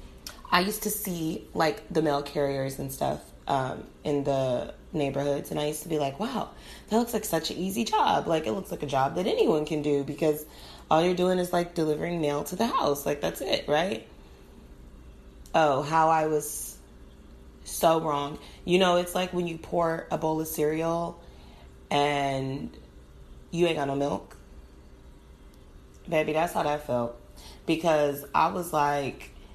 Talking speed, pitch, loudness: 175 wpm, 145 Hz, -28 LUFS